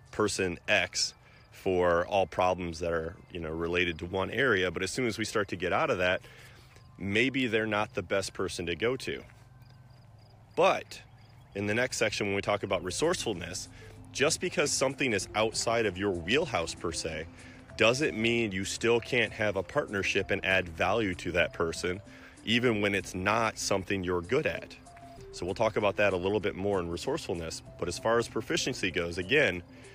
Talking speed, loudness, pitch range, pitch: 195 wpm, -30 LUFS, 95-120 Hz, 105 Hz